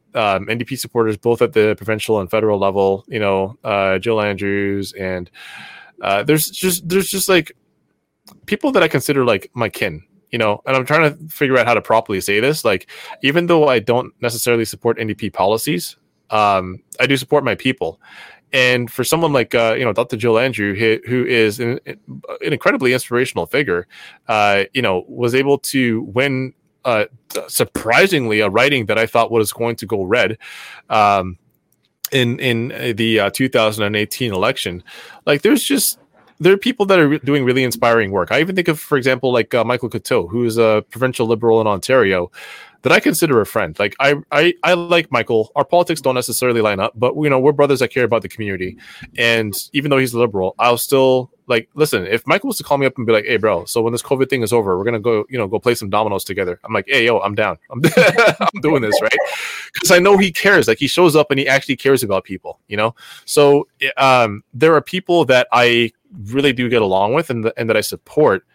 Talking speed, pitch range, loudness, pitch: 215 wpm, 110-140 Hz, -16 LUFS, 120 Hz